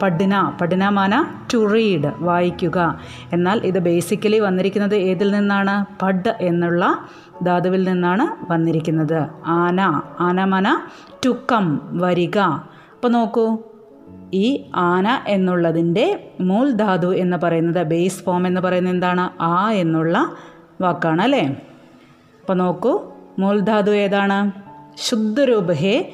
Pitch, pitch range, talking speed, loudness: 185 Hz, 175-205 Hz, 100 wpm, -19 LUFS